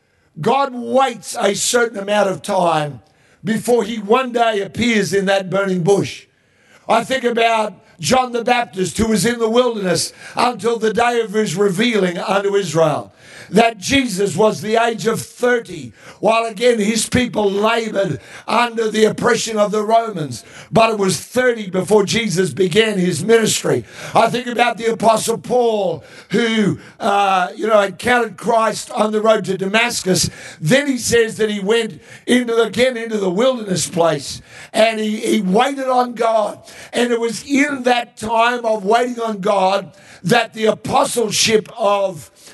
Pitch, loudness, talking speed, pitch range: 220 Hz, -17 LUFS, 160 wpm, 195-235 Hz